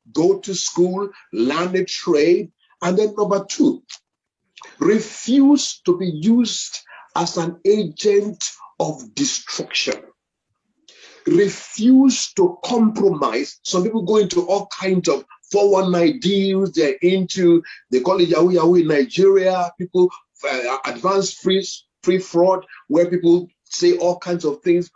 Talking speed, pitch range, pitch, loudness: 125 wpm, 175-215 Hz, 190 Hz, -18 LUFS